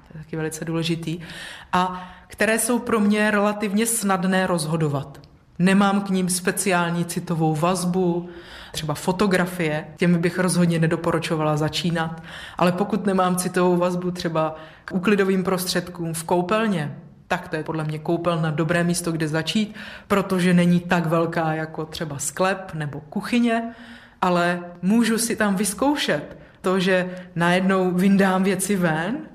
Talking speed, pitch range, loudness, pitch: 135 wpm, 165-195 Hz, -22 LUFS, 180 Hz